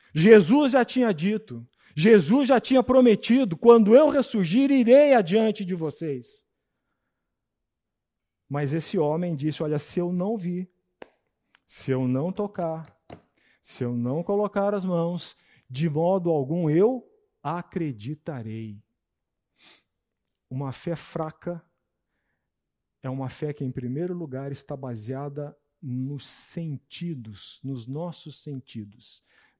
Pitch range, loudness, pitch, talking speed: 135-200 Hz, -23 LUFS, 165 Hz, 115 wpm